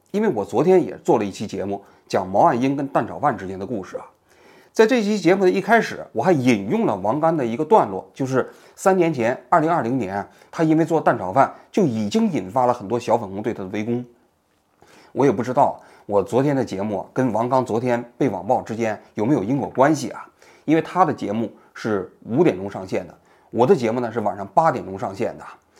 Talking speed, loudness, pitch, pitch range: 315 characters per minute, -21 LUFS, 130 Hz, 105-170 Hz